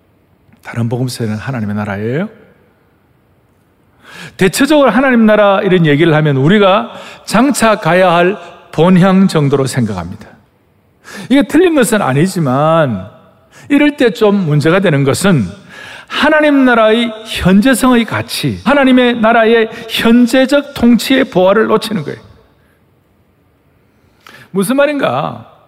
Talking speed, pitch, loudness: 255 characters per minute, 195 Hz, -11 LUFS